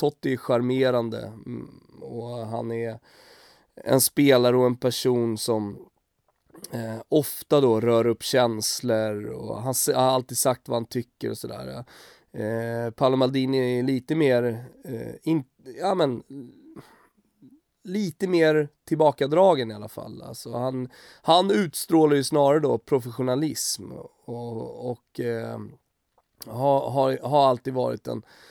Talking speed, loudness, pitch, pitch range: 130 wpm, -24 LUFS, 125 Hz, 115-145 Hz